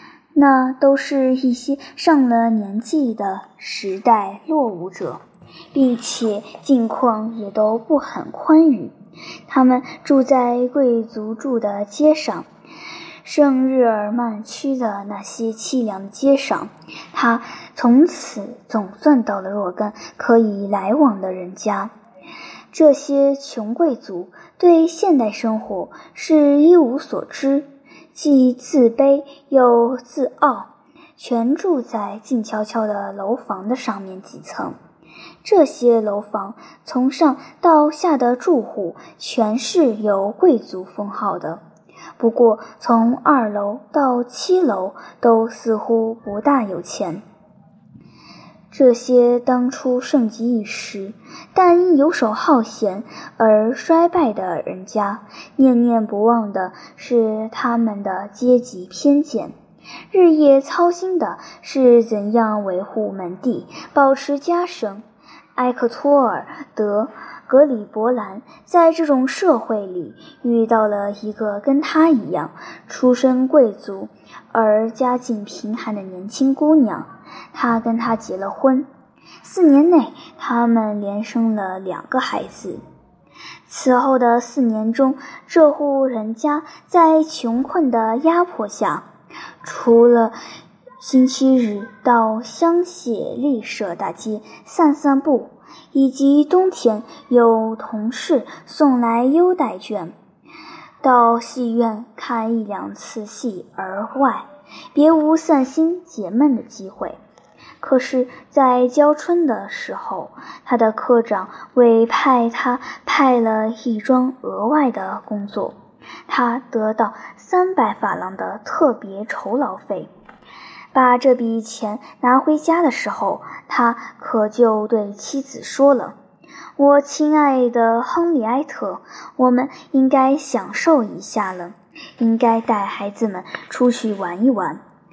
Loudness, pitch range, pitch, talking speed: -17 LUFS, 220-285 Hz, 245 Hz, 170 characters per minute